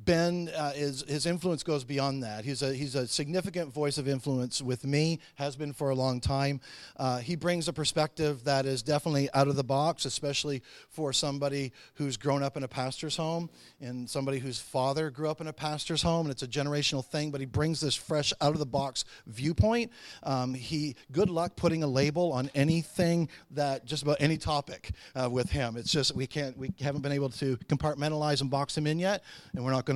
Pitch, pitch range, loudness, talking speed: 145 Hz, 135-155 Hz, -31 LUFS, 215 wpm